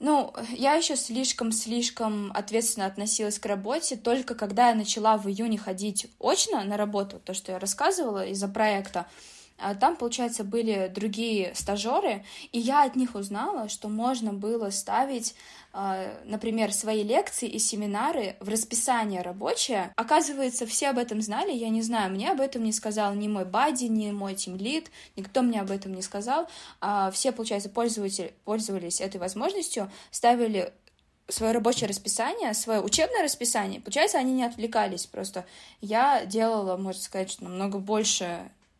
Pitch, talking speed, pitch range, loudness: 215 Hz, 150 wpm, 200-240 Hz, -27 LUFS